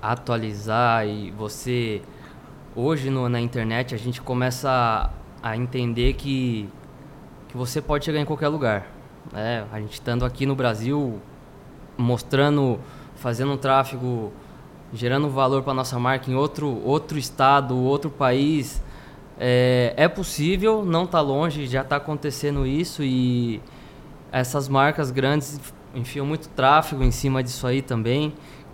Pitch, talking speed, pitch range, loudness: 130 Hz, 135 wpm, 120-145 Hz, -23 LUFS